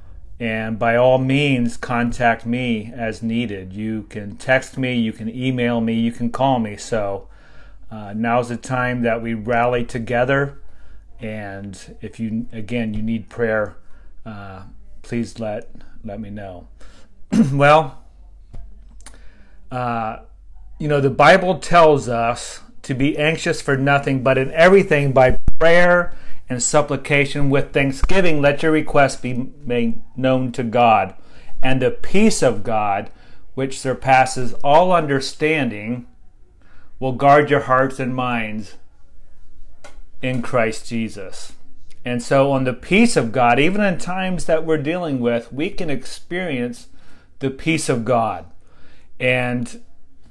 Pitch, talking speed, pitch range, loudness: 125 Hz, 135 wpm, 110-140 Hz, -19 LUFS